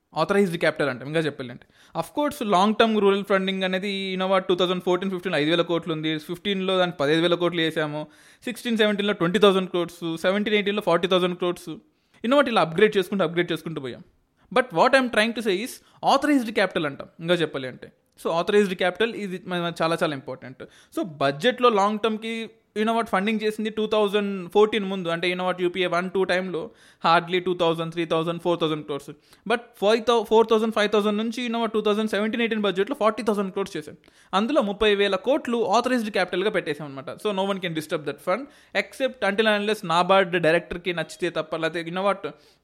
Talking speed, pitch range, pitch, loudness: 185 wpm, 170-215 Hz, 190 Hz, -23 LUFS